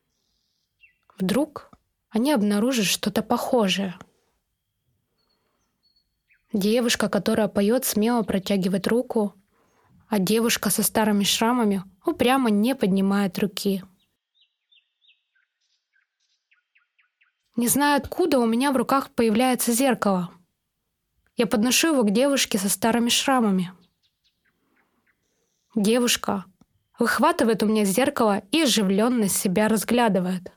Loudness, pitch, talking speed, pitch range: -22 LUFS, 225 Hz, 90 wpm, 205-245 Hz